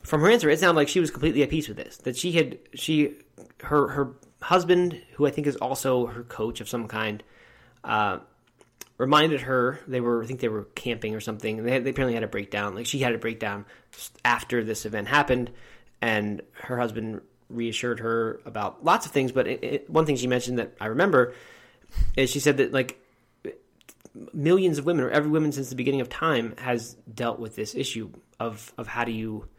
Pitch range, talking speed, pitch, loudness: 115-145 Hz, 210 wpm, 125 Hz, -26 LUFS